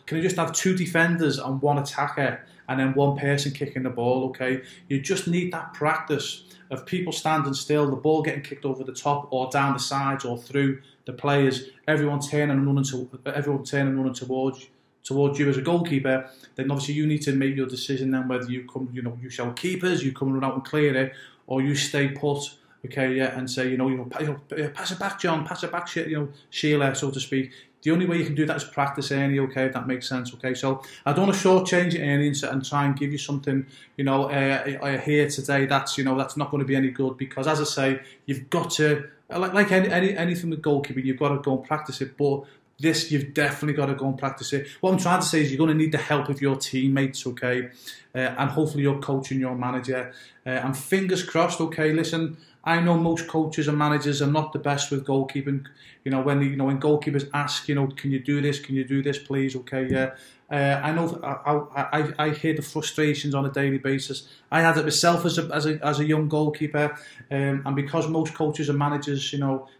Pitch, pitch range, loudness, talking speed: 140 Hz, 135-150 Hz, -25 LUFS, 240 wpm